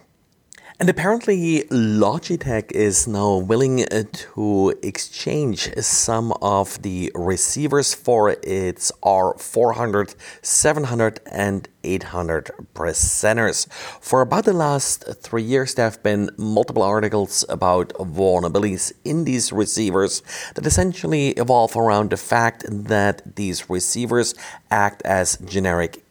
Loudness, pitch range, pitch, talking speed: -20 LUFS, 95-125 Hz, 105 Hz, 110 wpm